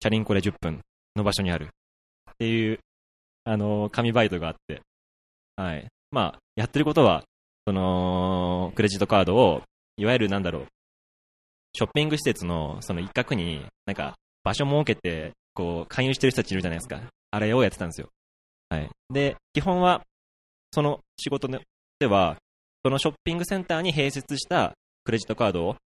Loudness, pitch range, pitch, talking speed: -26 LUFS, 80-130 Hz, 105 Hz, 345 characters per minute